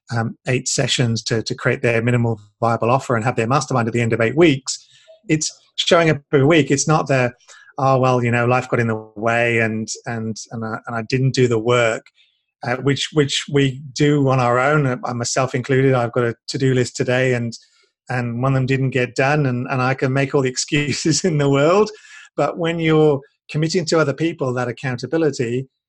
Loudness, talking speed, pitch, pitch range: -18 LUFS, 215 wpm, 130 Hz, 120-145 Hz